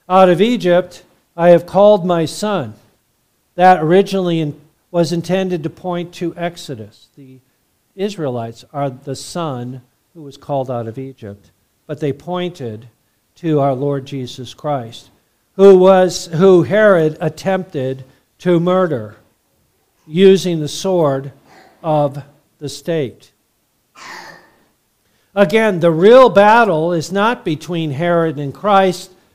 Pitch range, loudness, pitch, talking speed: 135-180 Hz, -14 LUFS, 160 Hz, 120 wpm